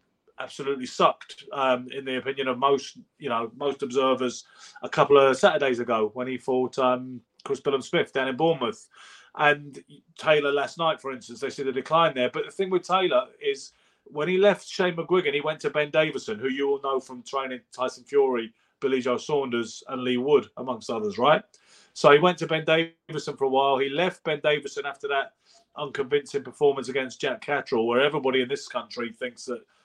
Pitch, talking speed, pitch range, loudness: 140 Hz, 195 wpm, 130-170 Hz, -25 LUFS